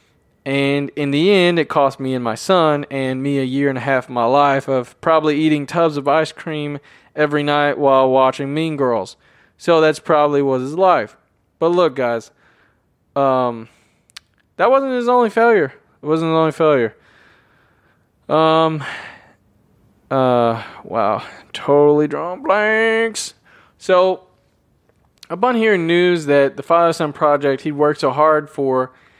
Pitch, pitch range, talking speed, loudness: 150 Hz, 135-165 Hz, 150 wpm, -16 LUFS